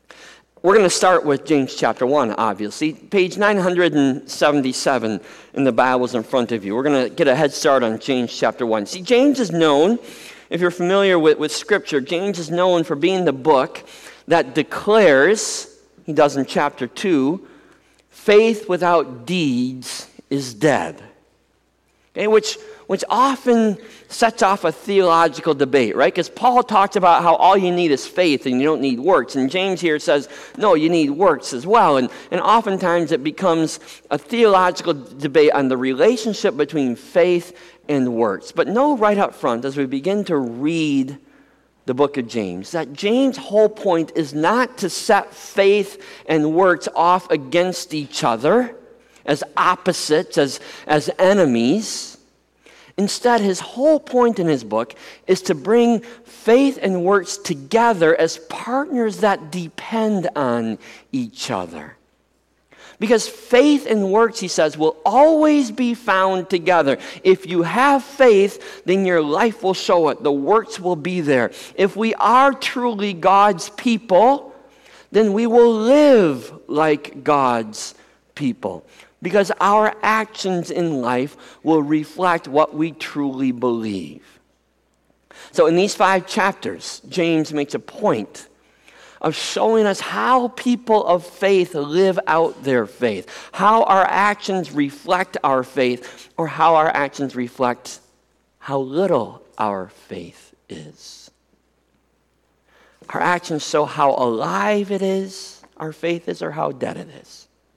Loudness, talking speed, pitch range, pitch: -18 LUFS, 150 wpm, 150-215 Hz, 180 Hz